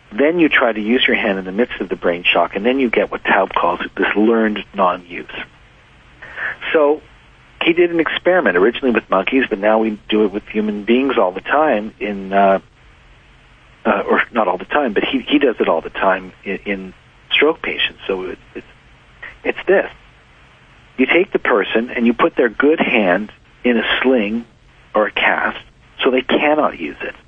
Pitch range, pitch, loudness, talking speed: 105-130 Hz, 110 Hz, -16 LUFS, 200 wpm